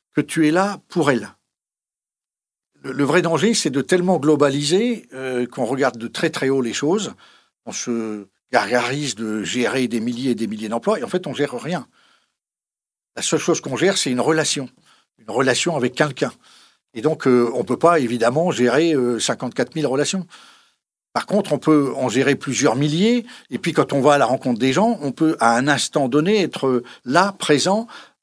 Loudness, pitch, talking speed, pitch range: -19 LUFS, 145 Hz, 195 wpm, 125-170 Hz